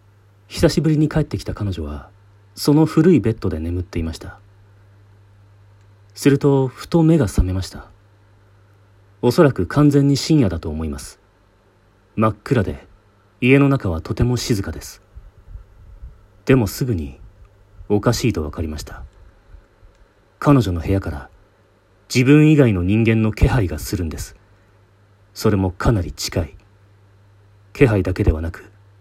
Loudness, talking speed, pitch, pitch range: -18 LUFS, 260 characters per minute, 100 Hz, 95-110 Hz